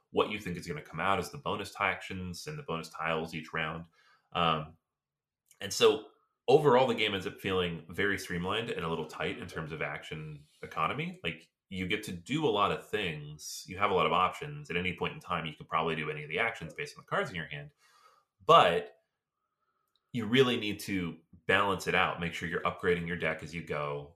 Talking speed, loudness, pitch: 225 wpm, -31 LUFS, 90 Hz